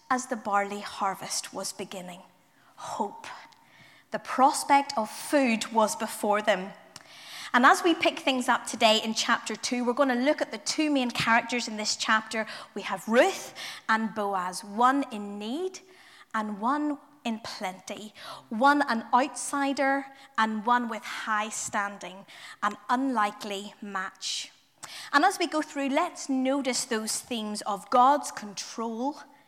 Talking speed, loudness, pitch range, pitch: 145 wpm, -27 LUFS, 210-280 Hz, 235 Hz